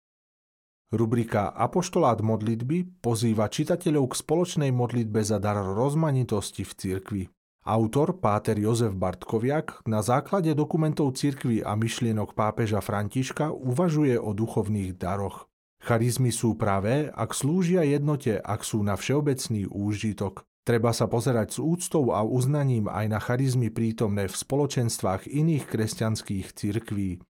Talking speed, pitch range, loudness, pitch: 125 wpm, 105-140 Hz, -26 LUFS, 115 Hz